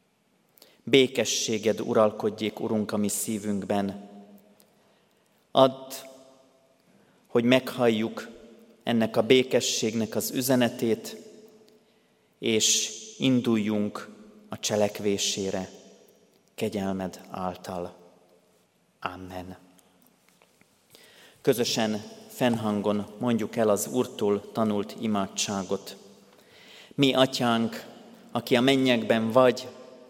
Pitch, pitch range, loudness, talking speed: 110 Hz, 100-130 Hz, -26 LUFS, 70 wpm